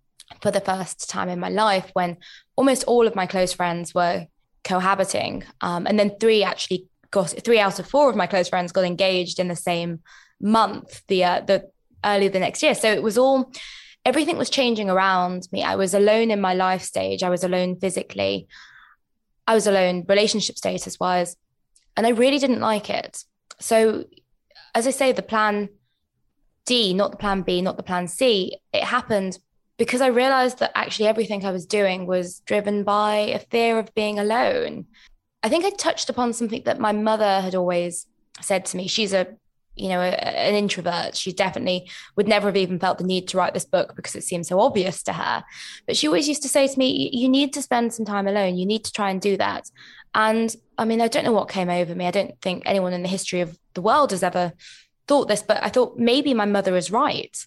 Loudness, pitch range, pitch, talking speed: -22 LUFS, 185-230 Hz, 200 Hz, 215 wpm